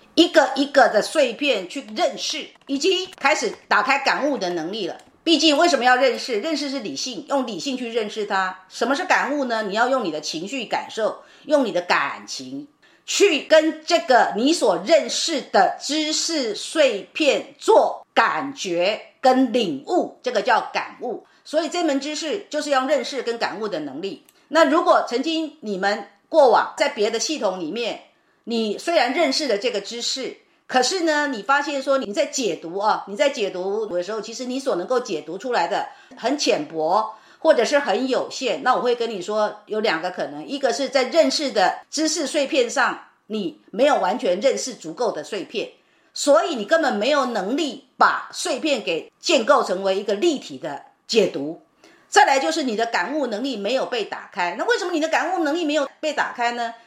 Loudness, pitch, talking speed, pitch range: -21 LUFS, 285 Hz, 270 characters per minute, 245-320 Hz